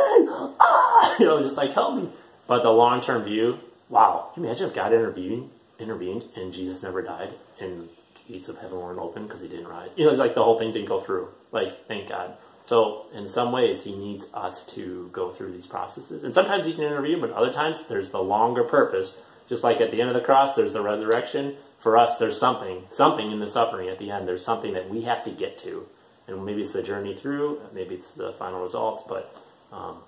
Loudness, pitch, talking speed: -24 LUFS, 115 Hz, 225 wpm